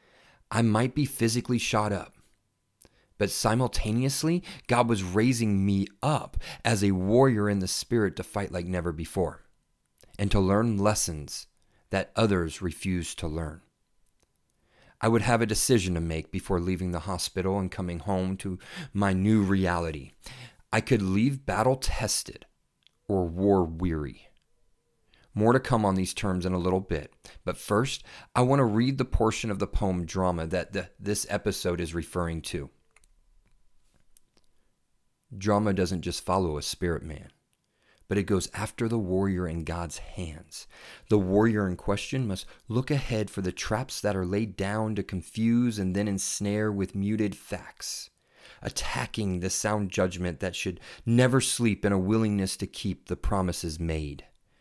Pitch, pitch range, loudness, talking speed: 100 Hz, 90-110 Hz, -28 LUFS, 155 wpm